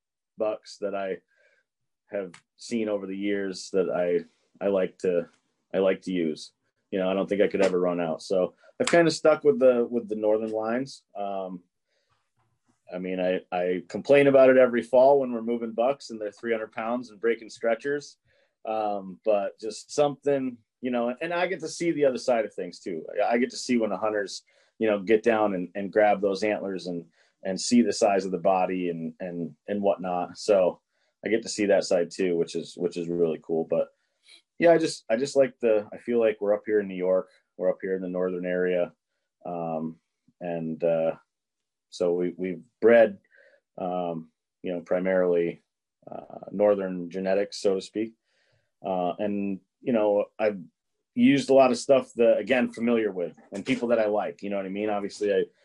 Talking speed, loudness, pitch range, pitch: 200 wpm, -26 LUFS, 90-120 Hz, 100 Hz